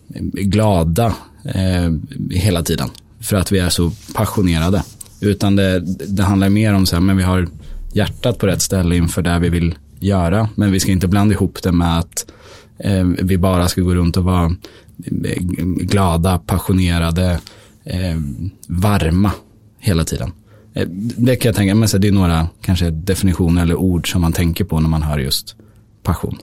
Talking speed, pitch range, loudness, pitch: 165 wpm, 85-100 Hz, -17 LUFS, 95 Hz